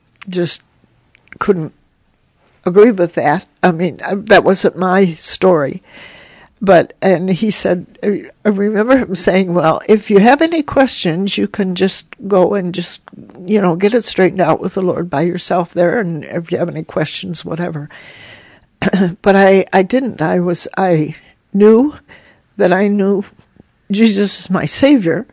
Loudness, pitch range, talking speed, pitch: -14 LUFS, 175-205 Hz, 155 wpm, 185 Hz